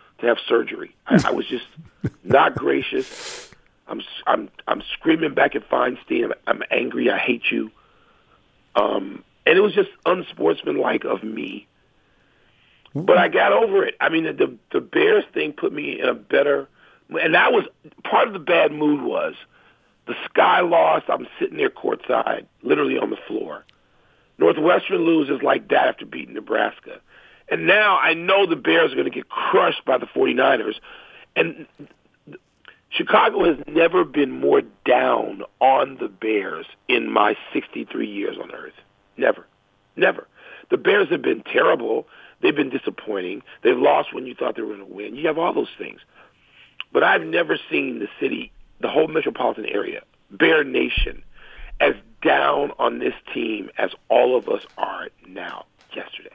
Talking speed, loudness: 165 wpm, -20 LUFS